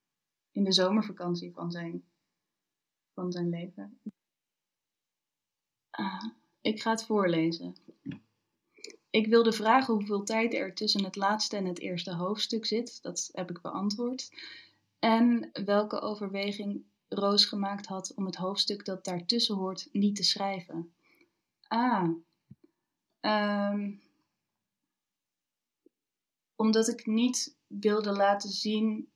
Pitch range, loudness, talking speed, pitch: 185-225 Hz, -30 LUFS, 110 wpm, 205 Hz